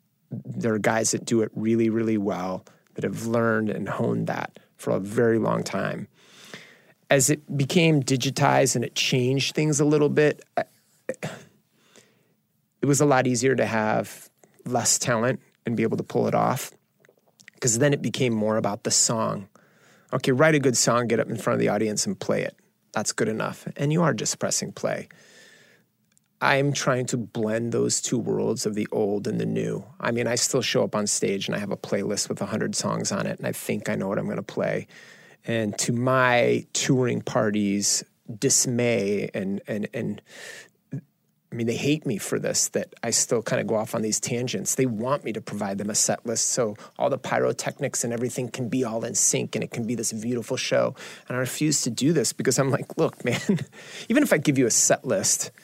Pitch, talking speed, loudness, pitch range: 125 Hz, 205 wpm, -24 LUFS, 110-140 Hz